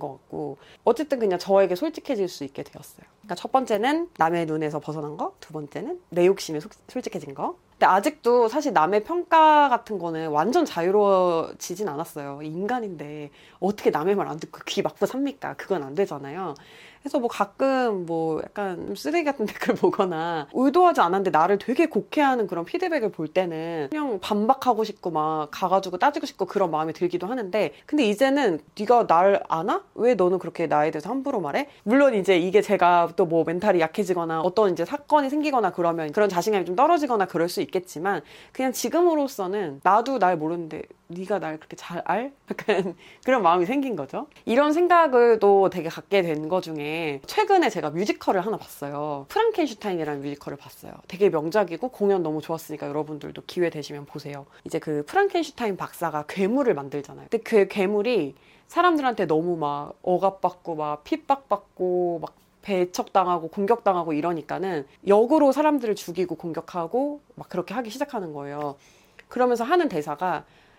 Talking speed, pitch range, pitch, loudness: 385 characters per minute, 165-245 Hz, 190 Hz, -24 LUFS